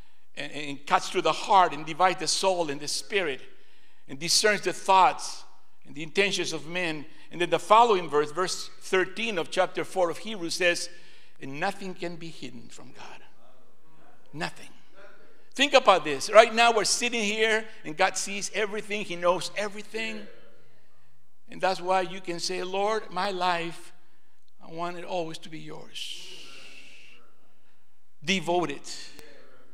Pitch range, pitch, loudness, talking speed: 160-200 Hz, 180 Hz, -26 LUFS, 150 wpm